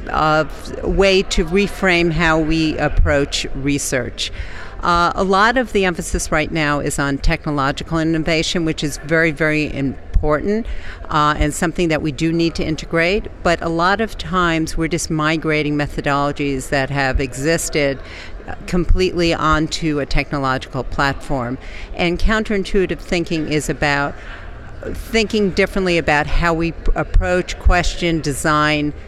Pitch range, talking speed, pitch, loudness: 145-175 Hz, 140 wpm, 160 Hz, -18 LUFS